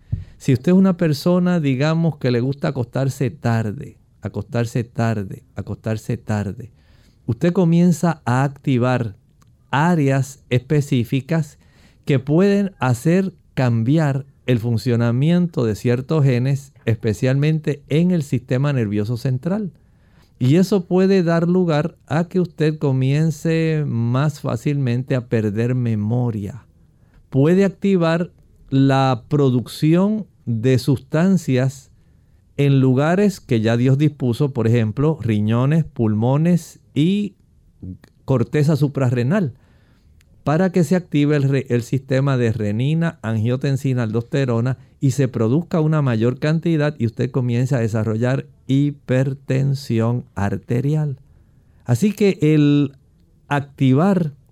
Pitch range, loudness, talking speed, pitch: 120-155 Hz, -19 LUFS, 105 wpm, 135 Hz